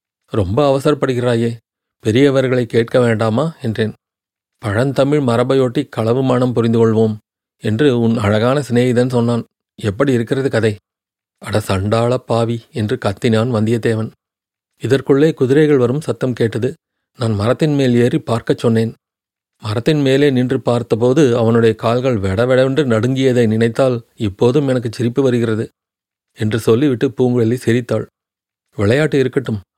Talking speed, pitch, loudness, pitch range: 115 wpm, 120 Hz, -15 LUFS, 115-135 Hz